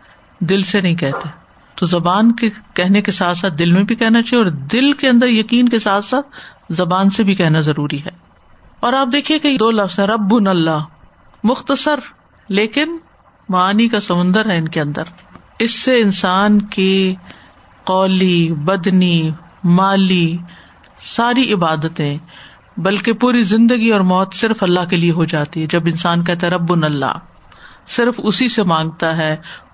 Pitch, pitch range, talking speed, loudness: 190 Hz, 170-225 Hz, 160 wpm, -15 LUFS